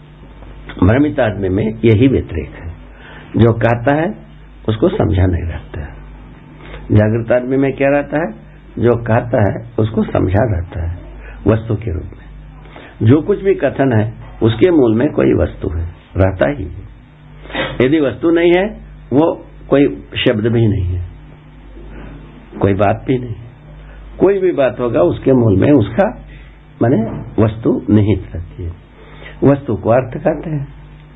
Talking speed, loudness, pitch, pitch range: 145 wpm, -15 LUFS, 115 Hz, 95-140 Hz